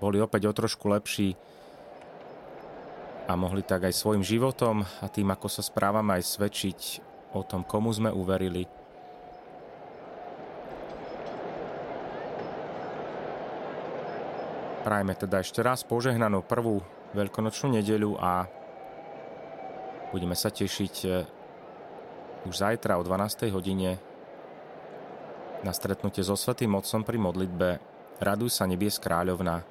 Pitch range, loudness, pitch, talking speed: 90-110 Hz, -30 LUFS, 100 Hz, 105 wpm